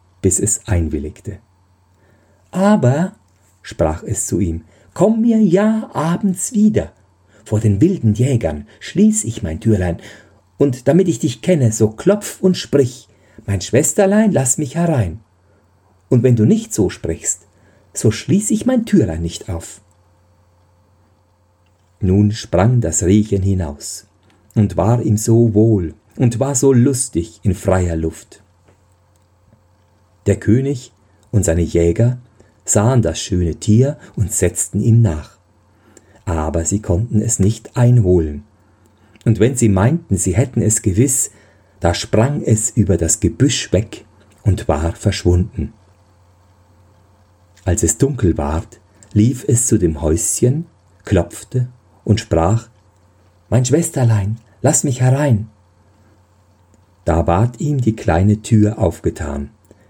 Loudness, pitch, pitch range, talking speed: -16 LUFS, 105 Hz, 90-115 Hz, 125 wpm